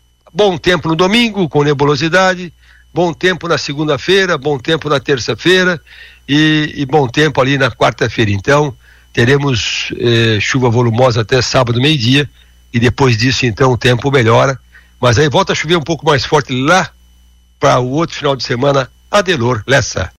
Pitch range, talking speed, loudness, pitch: 125-160 Hz, 160 wpm, -12 LUFS, 140 Hz